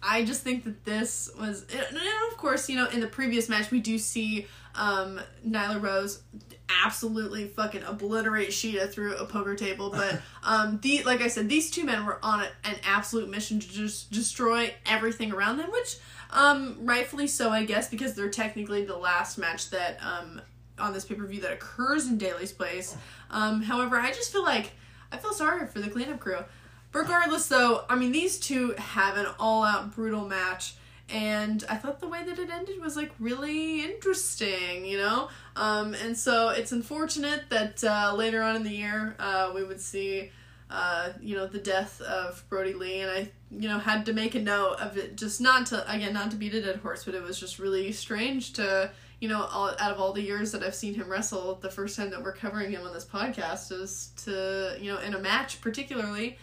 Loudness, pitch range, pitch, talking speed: -29 LUFS, 195-240 Hz, 215 Hz, 210 wpm